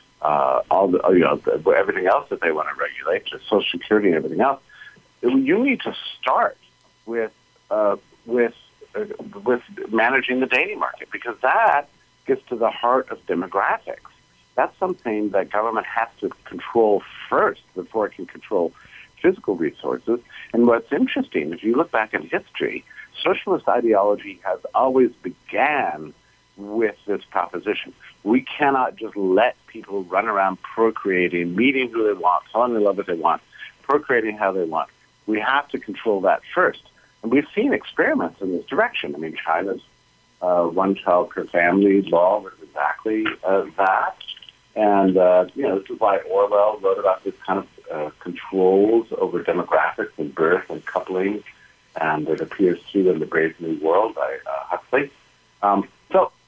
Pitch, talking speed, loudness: 115 Hz, 160 wpm, -21 LUFS